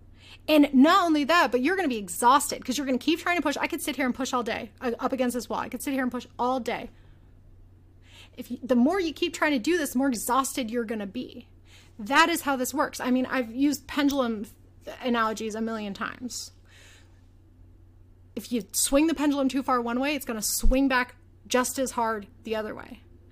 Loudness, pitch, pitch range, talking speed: -26 LUFS, 250 Hz, 220-280 Hz, 220 wpm